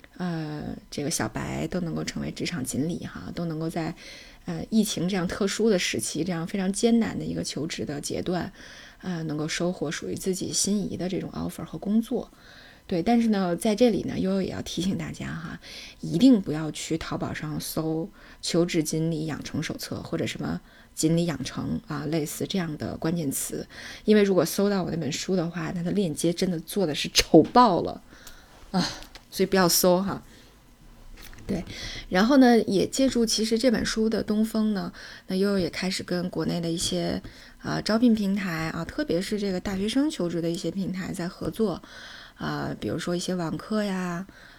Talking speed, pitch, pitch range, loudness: 280 characters per minute, 180 Hz, 165-210 Hz, -26 LUFS